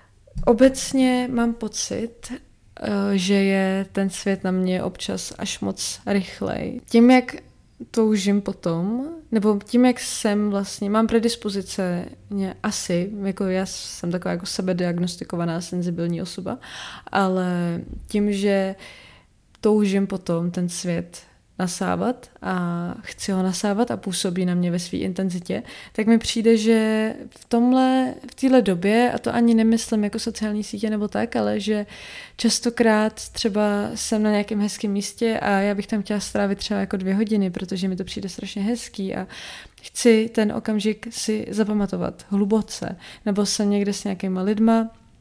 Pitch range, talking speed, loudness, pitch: 190-225 Hz, 145 wpm, -22 LUFS, 205 Hz